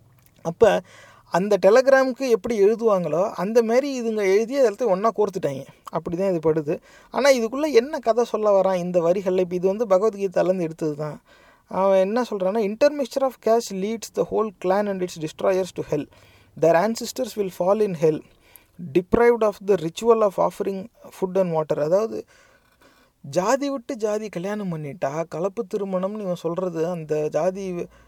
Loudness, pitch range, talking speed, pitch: -22 LUFS, 170-225 Hz, 155 wpm, 195 Hz